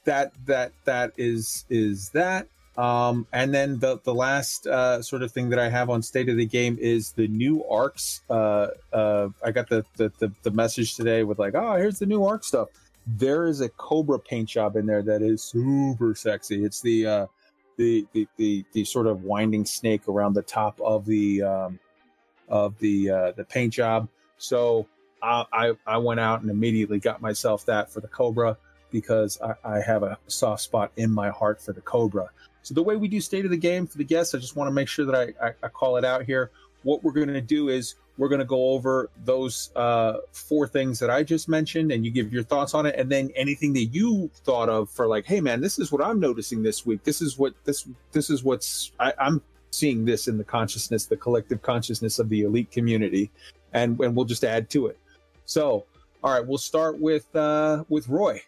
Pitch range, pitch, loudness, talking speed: 110-140 Hz, 120 Hz, -25 LUFS, 220 wpm